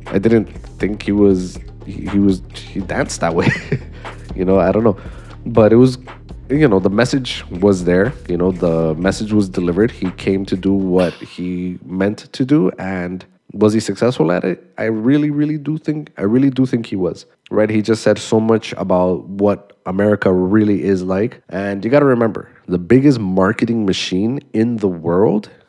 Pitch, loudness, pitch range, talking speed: 100 Hz, -16 LUFS, 95-115 Hz, 190 wpm